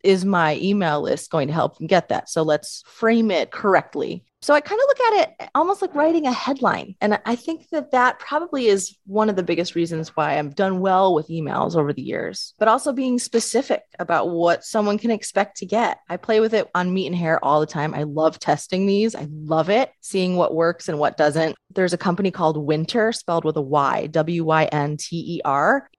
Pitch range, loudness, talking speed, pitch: 160-225 Hz, -21 LUFS, 215 wpm, 185 Hz